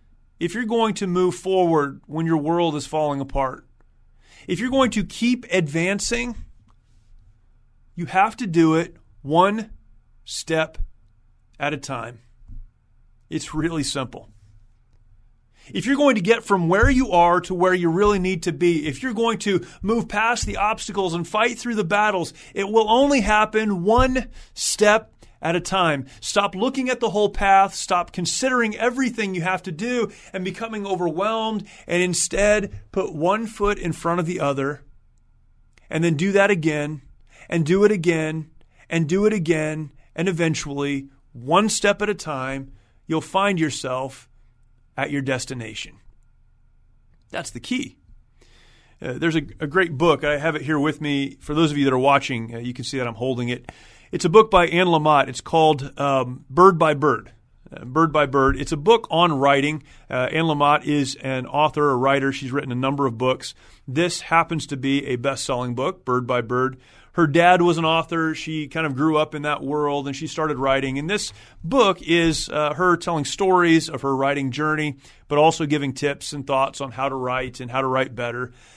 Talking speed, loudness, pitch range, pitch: 185 wpm, -21 LUFS, 135-185 Hz, 155 Hz